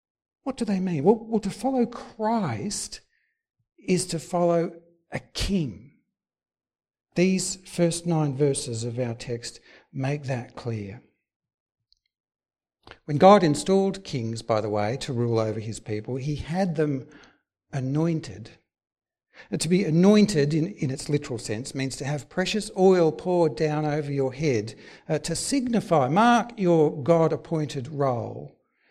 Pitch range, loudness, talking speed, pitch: 135-185 Hz, -25 LUFS, 135 wpm, 155 Hz